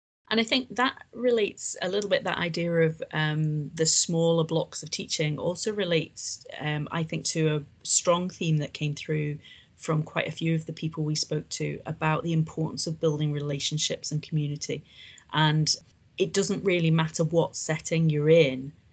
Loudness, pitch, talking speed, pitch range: -27 LUFS, 160 Hz, 180 wpm, 150-170 Hz